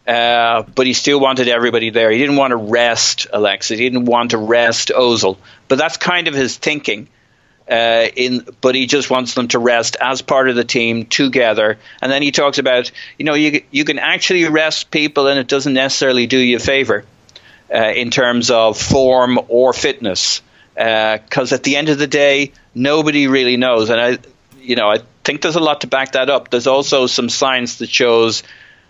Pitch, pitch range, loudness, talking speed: 130 Hz, 120-140 Hz, -14 LUFS, 205 wpm